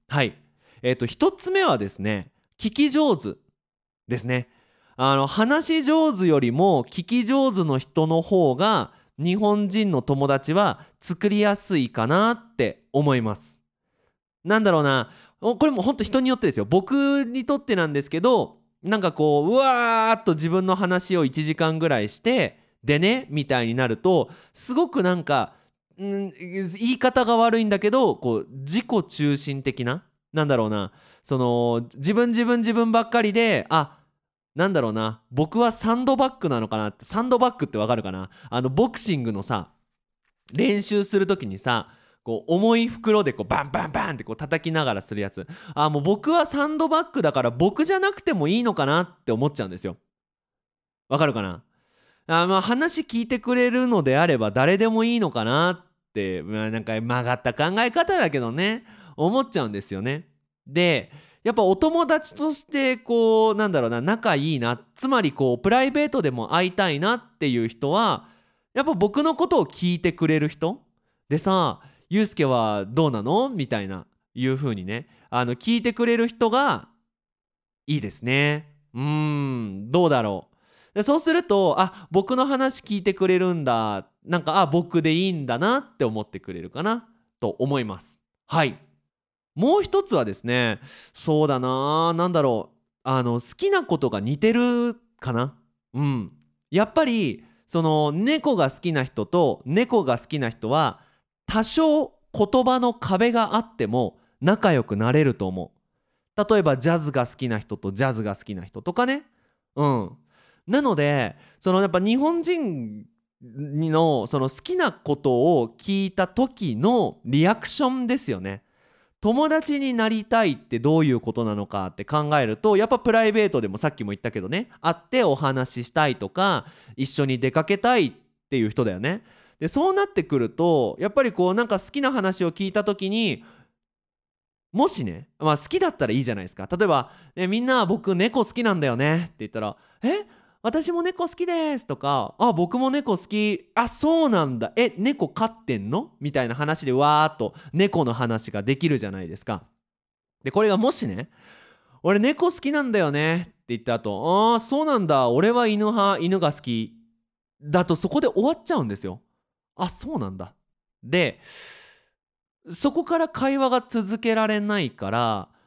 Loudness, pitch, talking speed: -23 LUFS, 175 Hz, 325 characters per minute